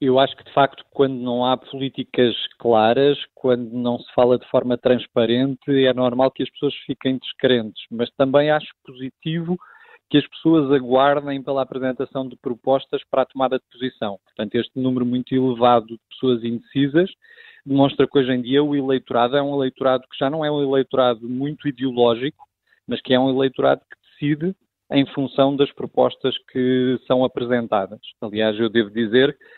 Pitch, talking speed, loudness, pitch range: 130 Hz, 170 wpm, -20 LUFS, 125-140 Hz